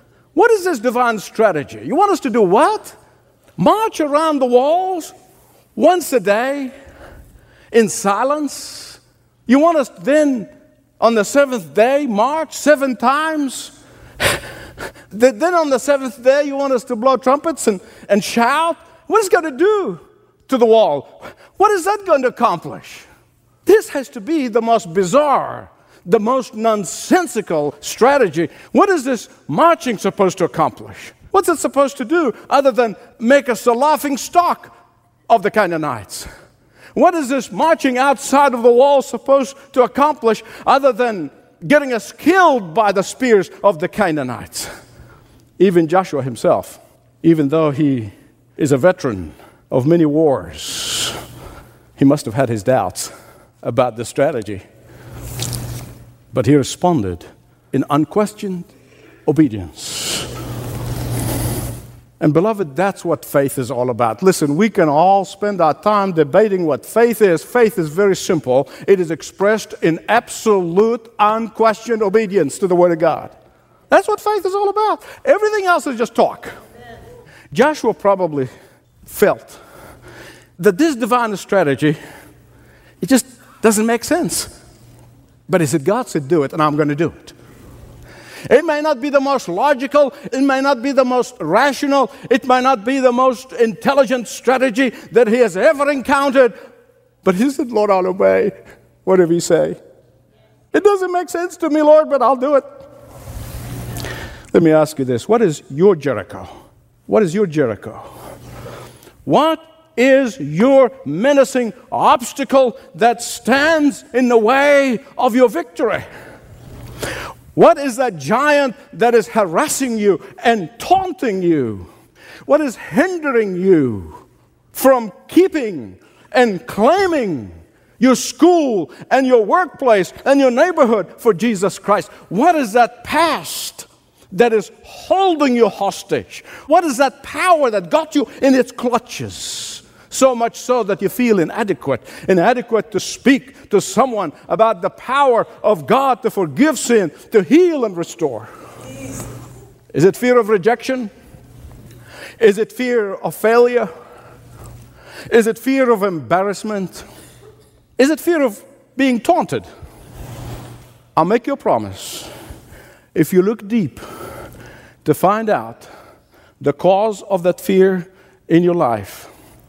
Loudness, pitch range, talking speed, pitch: -16 LUFS, 175-275 Hz, 140 wpm, 230 Hz